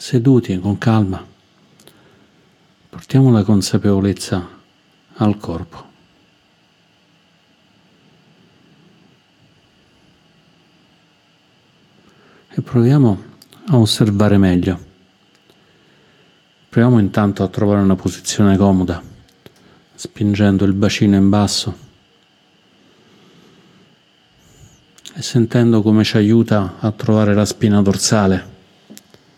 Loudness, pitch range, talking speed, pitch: -15 LUFS, 95-110 Hz, 70 wpm, 105 Hz